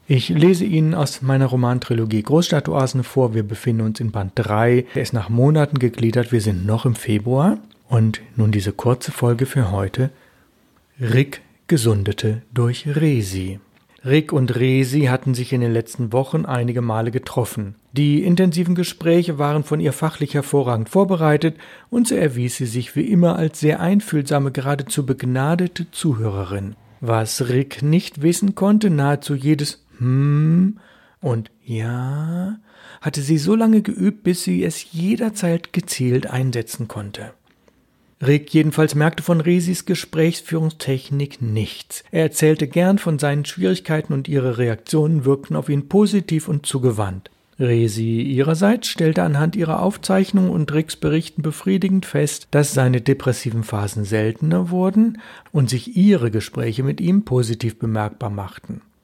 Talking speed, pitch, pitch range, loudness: 140 wpm, 140 Hz, 120-165 Hz, -19 LUFS